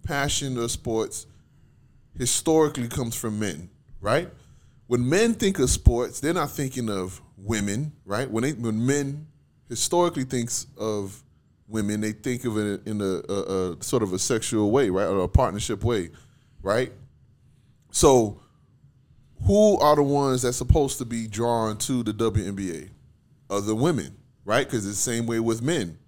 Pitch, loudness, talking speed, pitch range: 115 Hz, -25 LUFS, 160 wpm, 105-135 Hz